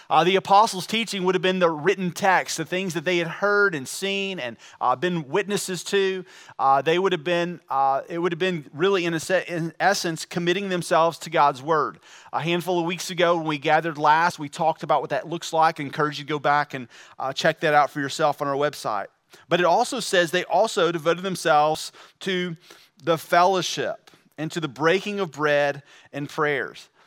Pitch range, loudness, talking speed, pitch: 155-185 Hz, -23 LUFS, 210 wpm, 170 Hz